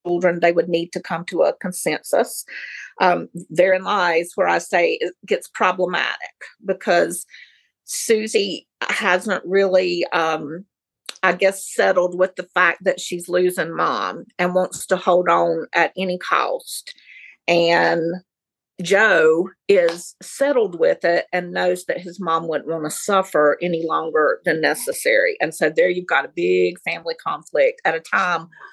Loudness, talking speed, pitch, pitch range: -19 LUFS, 150 wpm, 180 Hz, 170-200 Hz